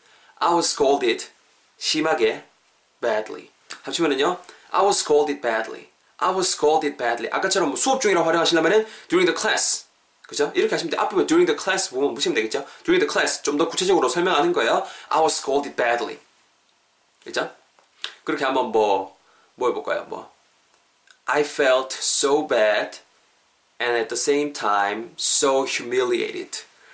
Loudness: -20 LUFS